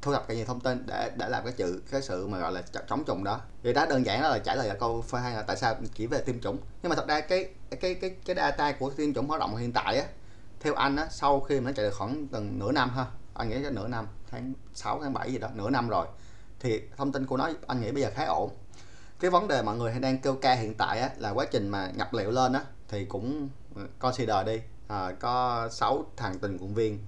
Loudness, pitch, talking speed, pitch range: -30 LUFS, 120 Hz, 275 wpm, 105-135 Hz